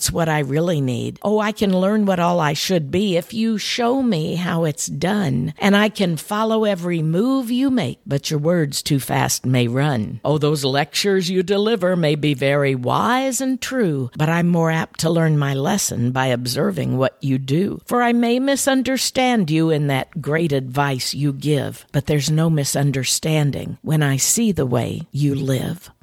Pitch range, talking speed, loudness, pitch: 140-200 Hz, 185 wpm, -19 LUFS, 160 Hz